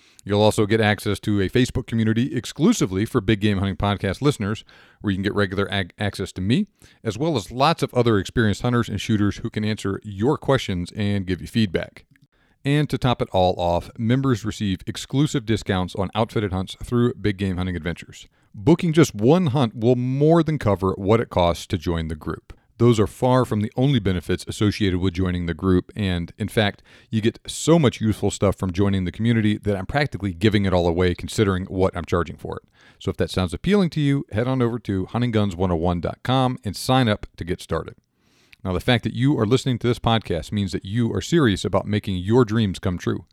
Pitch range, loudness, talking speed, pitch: 95-120 Hz, -22 LUFS, 210 wpm, 105 Hz